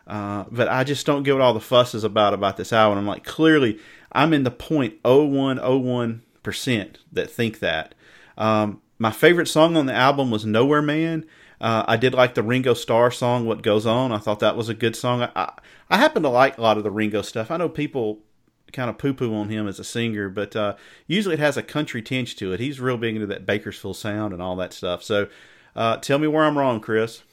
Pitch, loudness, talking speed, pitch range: 115 Hz, -21 LUFS, 230 wpm, 105-130 Hz